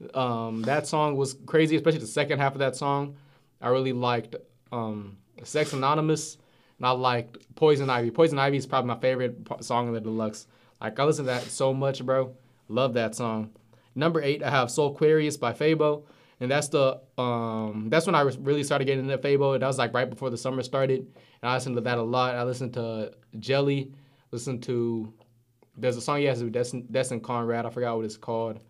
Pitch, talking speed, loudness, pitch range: 130 Hz, 210 wpm, -27 LUFS, 120-140 Hz